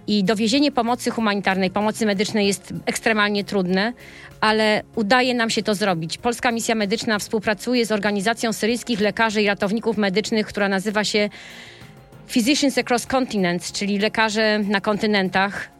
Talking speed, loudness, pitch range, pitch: 135 wpm, -20 LUFS, 205-230 Hz, 215 Hz